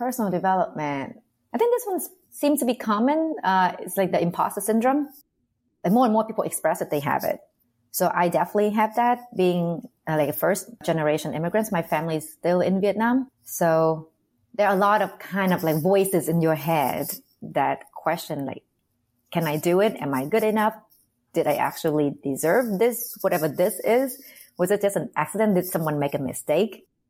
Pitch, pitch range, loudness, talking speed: 185 Hz, 160-220 Hz, -24 LUFS, 190 wpm